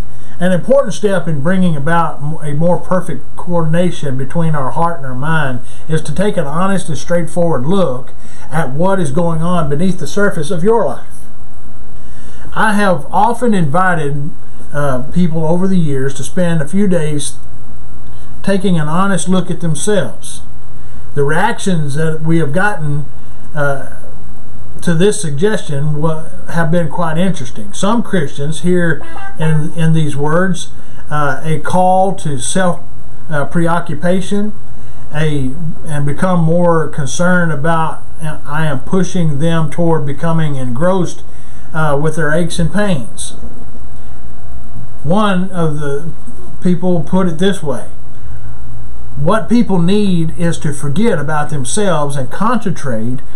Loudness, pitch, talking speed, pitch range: -16 LUFS, 165 Hz, 135 wpm, 145-180 Hz